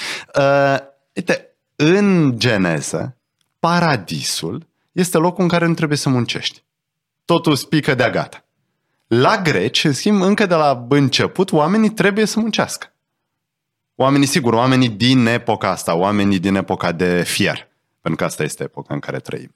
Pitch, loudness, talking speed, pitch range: 145 Hz, -17 LUFS, 145 wpm, 125-170 Hz